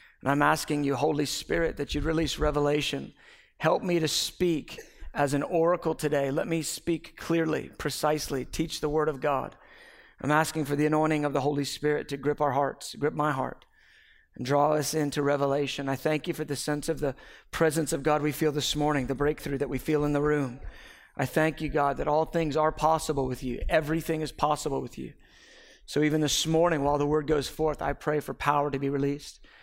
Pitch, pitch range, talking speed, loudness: 150 Hz, 145-155 Hz, 210 wpm, -28 LUFS